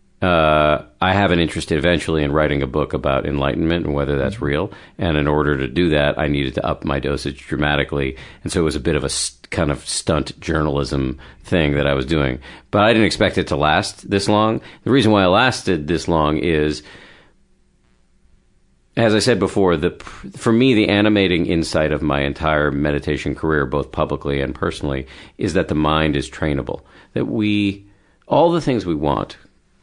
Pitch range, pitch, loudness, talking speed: 70-90 Hz, 75 Hz, -18 LUFS, 195 wpm